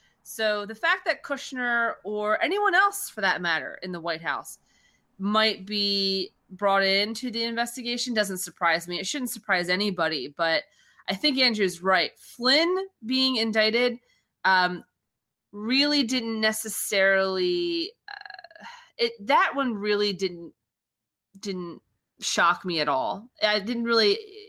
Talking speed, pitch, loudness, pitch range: 130 wpm, 215 Hz, -25 LUFS, 190-255 Hz